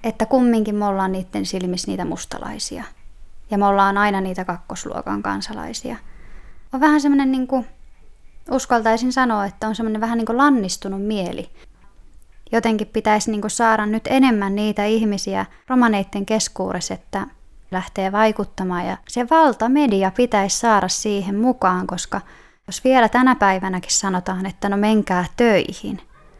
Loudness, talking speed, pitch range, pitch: -19 LUFS, 140 wpm, 190-235 Hz, 210 Hz